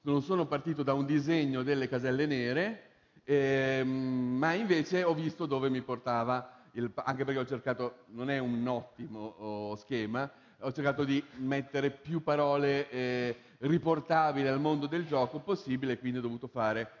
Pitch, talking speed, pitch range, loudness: 135 Hz, 155 wpm, 125-150 Hz, -32 LUFS